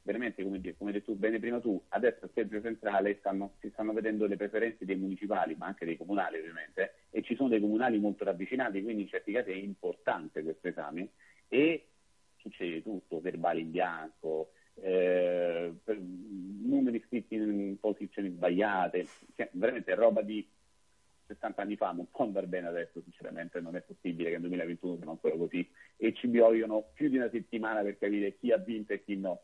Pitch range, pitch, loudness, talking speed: 90-110 Hz, 100 Hz, -33 LUFS, 180 wpm